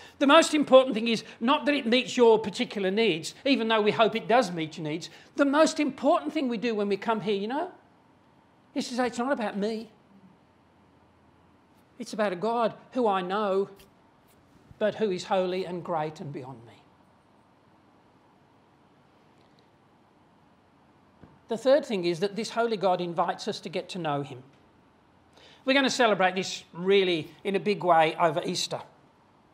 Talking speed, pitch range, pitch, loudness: 170 wpm, 180-240 Hz, 210 Hz, -26 LUFS